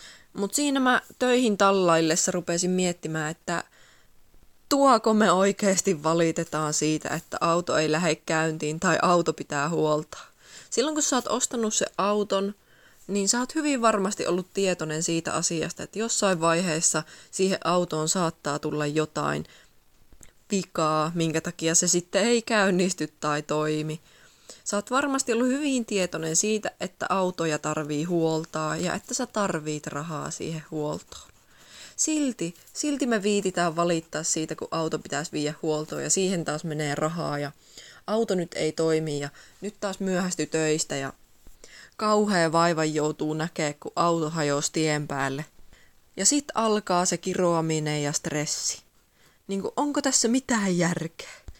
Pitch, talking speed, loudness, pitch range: 170 Hz, 140 wpm, -25 LUFS, 155-200 Hz